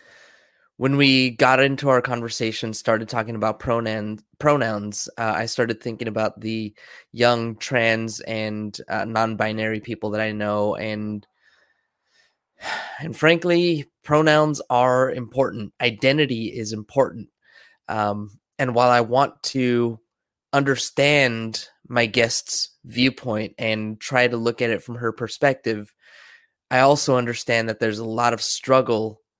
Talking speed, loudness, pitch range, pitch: 130 wpm, -21 LUFS, 110-130 Hz, 115 Hz